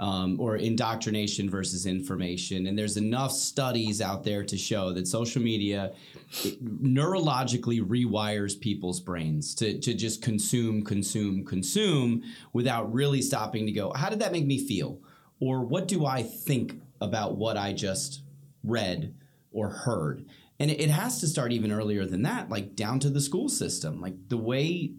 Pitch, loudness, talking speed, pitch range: 115 Hz, -29 LUFS, 160 wpm, 100-135 Hz